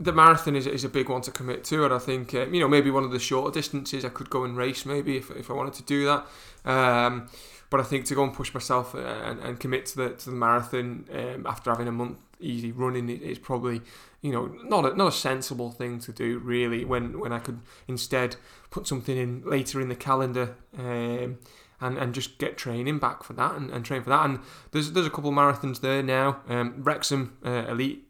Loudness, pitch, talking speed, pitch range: -27 LUFS, 130 Hz, 240 wpm, 125-140 Hz